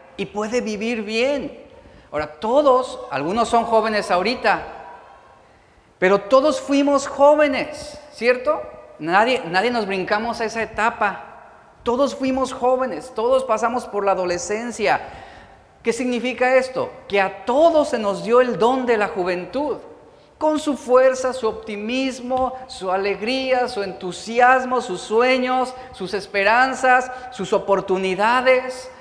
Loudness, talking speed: -20 LUFS, 120 wpm